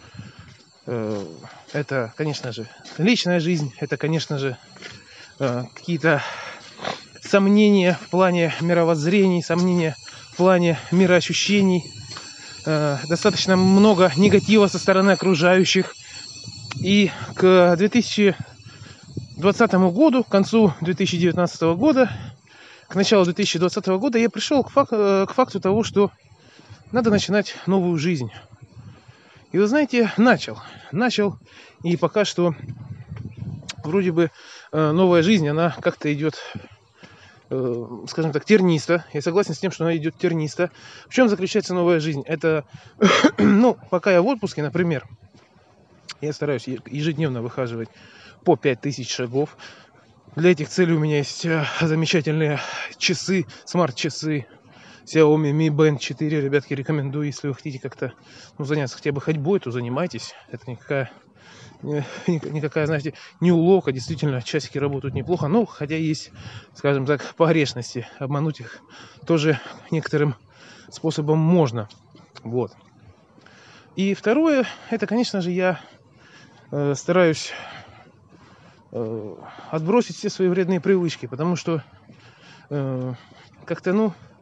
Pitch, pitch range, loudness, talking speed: 160 Hz, 135-185 Hz, -21 LUFS, 115 wpm